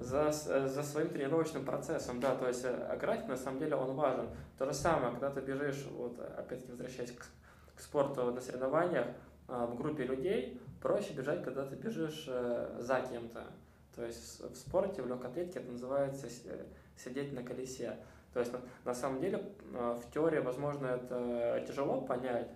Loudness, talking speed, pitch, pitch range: -38 LUFS, 170 wpm, 125 Hz, 120-140 Hz